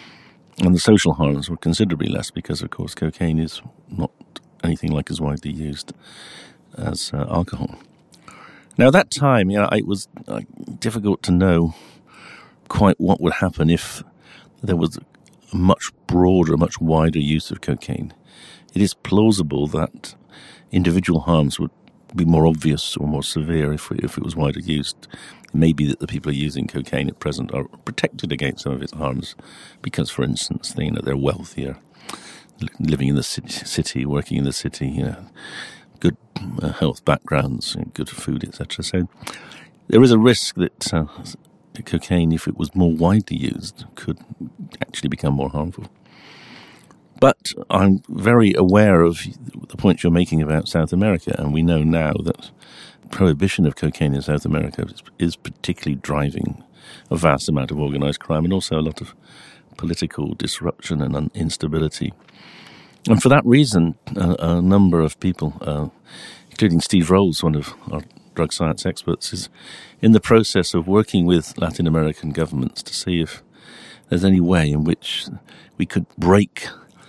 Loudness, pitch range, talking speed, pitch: -20 LUFS, 75-95 Hz, 165 wpm, 80 Hz